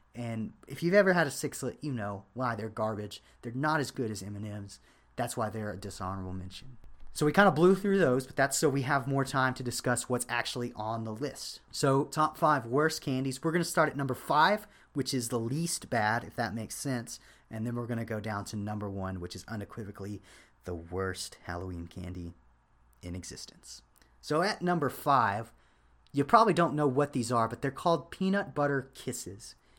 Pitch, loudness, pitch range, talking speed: 120 Hz, -31 LUFS, 105-145 Hz, 205 wpm